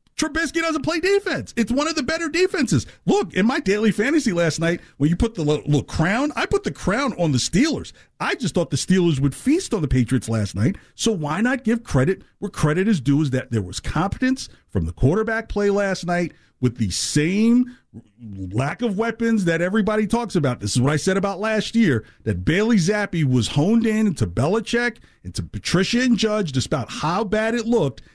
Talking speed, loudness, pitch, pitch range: 215 wpm, -21 LUFS, 190 Hz, 135-230 Hz